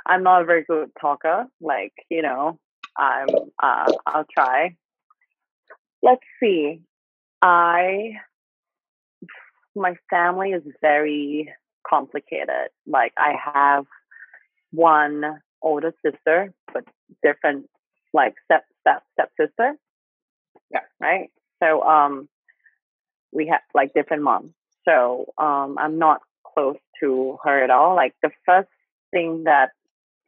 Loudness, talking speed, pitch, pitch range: -20 LUFS, 115 wpm, 160 Hz, 145-185 Hz